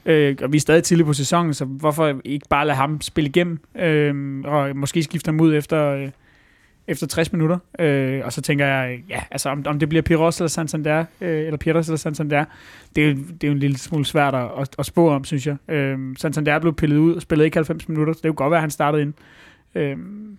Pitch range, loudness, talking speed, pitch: 140-160 Hz, -20 LUFS, 245 wpm, 150 Hz